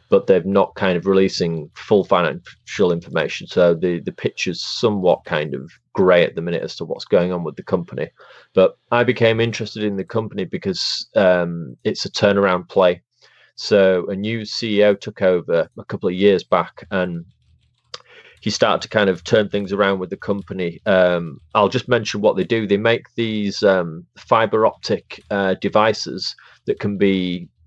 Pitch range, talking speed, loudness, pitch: 90-105 Hz, 180 wpm, -19 LUFS, 100 Hz